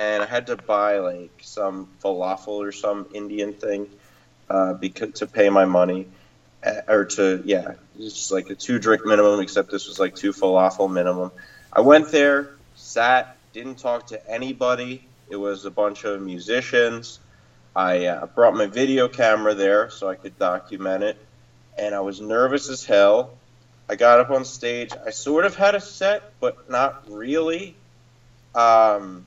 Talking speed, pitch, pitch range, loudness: 170 wpm, 105 Hz, 95-125 Hz, -21 LUFS